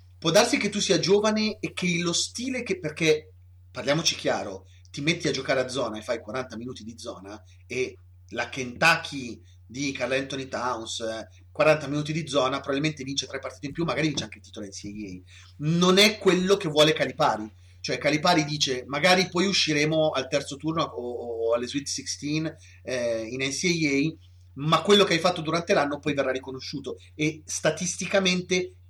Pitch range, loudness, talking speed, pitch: 110-165 Hz, -25 LUFS, 175 wpm, 140 Hz